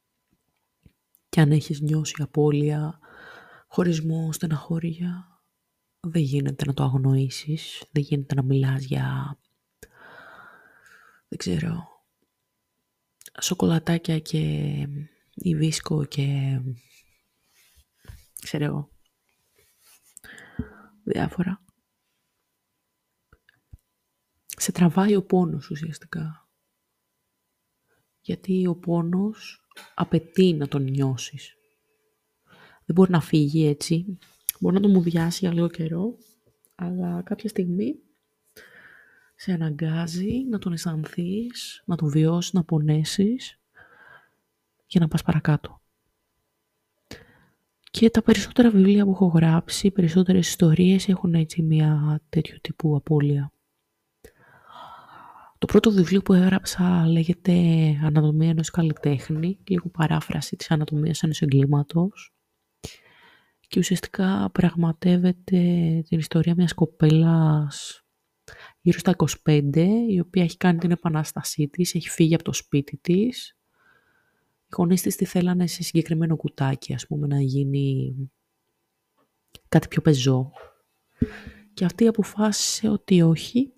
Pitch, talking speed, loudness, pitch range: 165 Hz, 100 wpm, -23 LUFS, 150-185 Hz